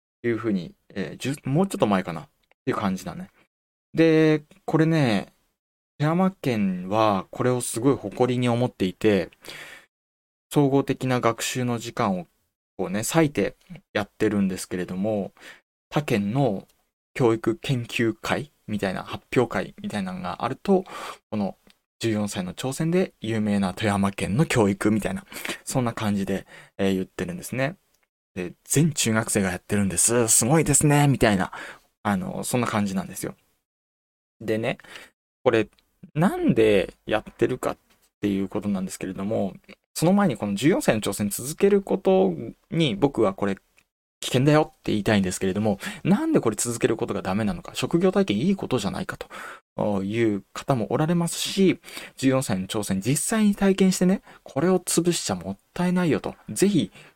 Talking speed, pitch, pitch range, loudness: 315 characters per minute, 120 Hz, 100-165 Hz, -24 LUFS